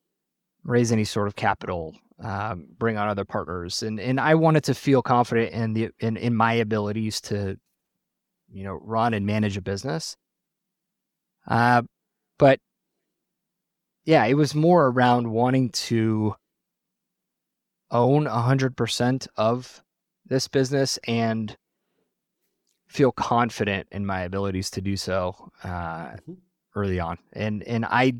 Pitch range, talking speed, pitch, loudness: 100-130 Hz, 130 wpm, 115 Hz, -24 LUFS